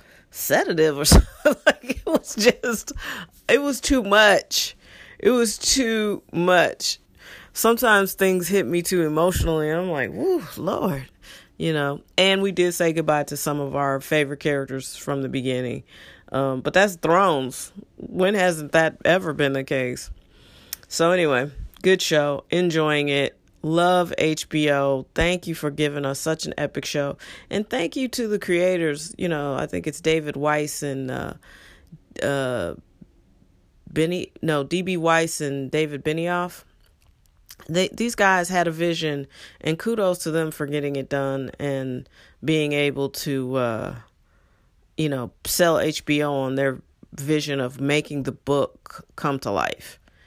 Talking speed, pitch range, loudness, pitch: 150 wpm, 135-180 Hz, -22 LUFS, 155 Hz